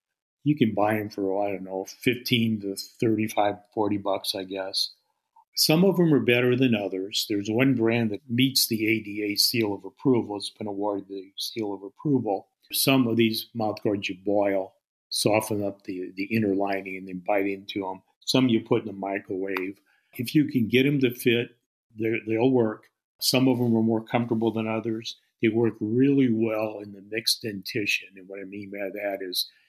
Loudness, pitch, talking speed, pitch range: -25 LUFS, 110 Hz, 190 wpm, 100-120 Hz